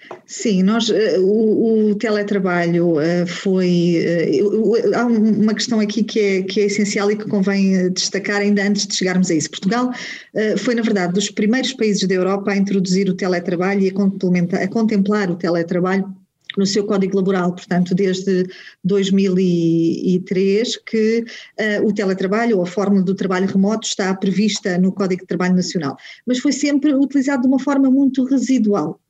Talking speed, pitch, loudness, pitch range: 160 wpm, 200 Hz, -17 LUFS, 185-215 Hz